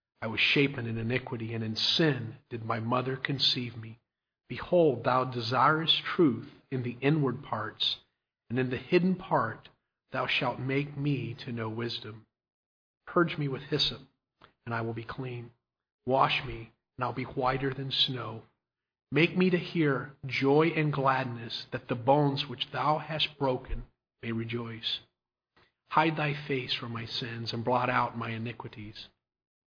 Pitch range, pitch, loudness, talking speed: 115-140 Hz, 130 Hz, -29 LUFS, 160 wpm